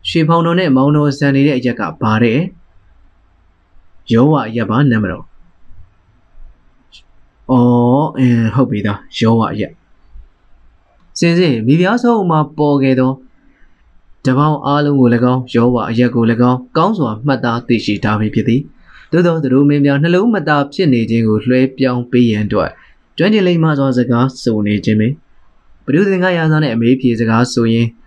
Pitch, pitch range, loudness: 125 Hz, 110-145 Hz, -13 LUFS